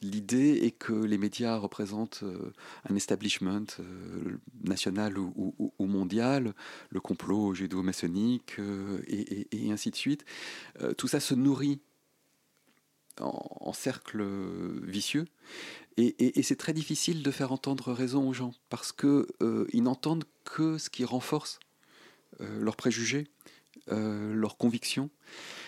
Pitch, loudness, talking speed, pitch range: 115 Hz, -32 LUFS, 130 wpm, 100-140 Hz